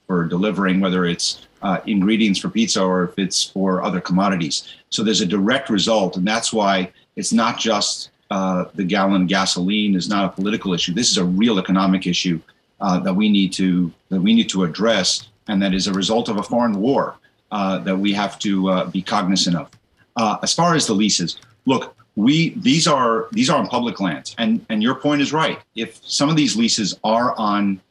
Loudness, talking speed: -19 LUFS, 205 wpm